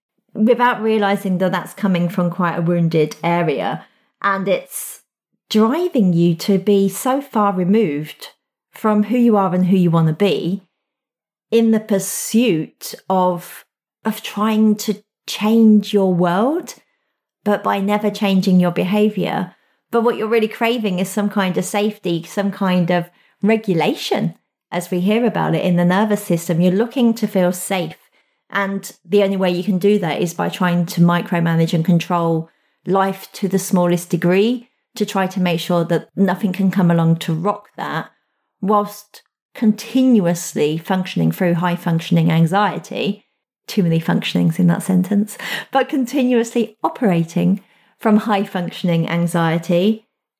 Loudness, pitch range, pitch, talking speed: -18 LUFS, 175-215 Hz, 195 Hz, 150 wpm